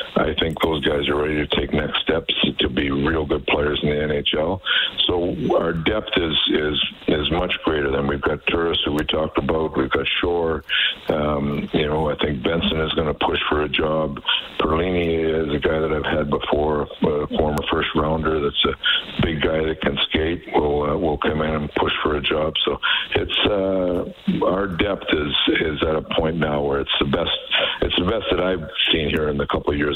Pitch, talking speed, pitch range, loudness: 75 Hz, 210 wpm, 75-80 Hz, -20 LUFS